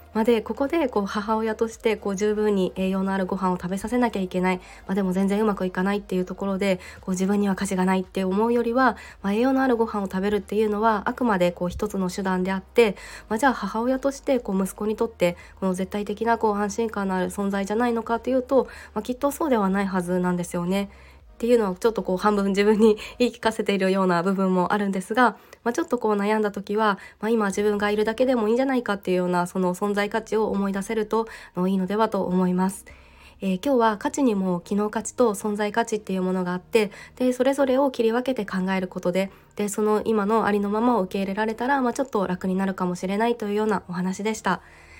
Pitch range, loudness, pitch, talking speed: 190-230 Hz, -24 LUFS, 205 Hz, 485 characters per minute